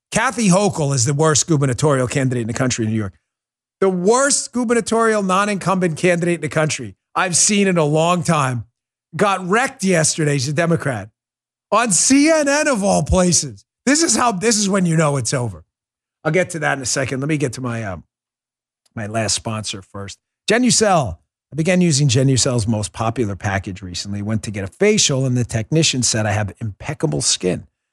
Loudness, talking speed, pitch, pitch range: -17 LUFS, 185 wpm, 145 Hz, 115-185 Hz